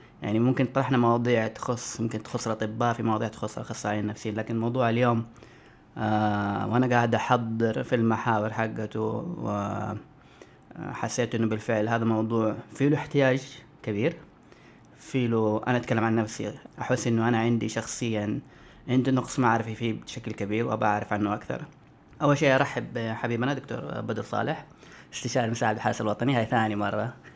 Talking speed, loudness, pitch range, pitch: 145 wpm, -27 LUFS, 110-125 Hz, 115 Hz